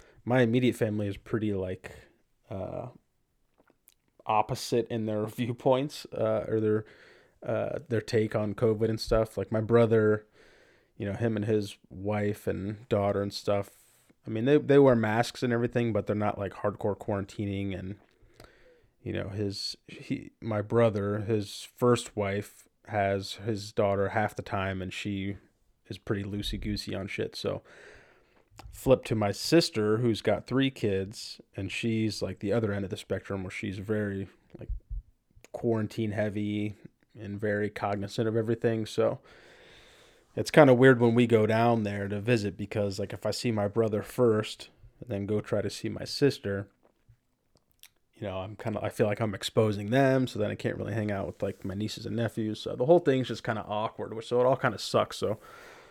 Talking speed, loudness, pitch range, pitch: 175 wpm, -29 LUFS, 100-120 Hz, 110 Hz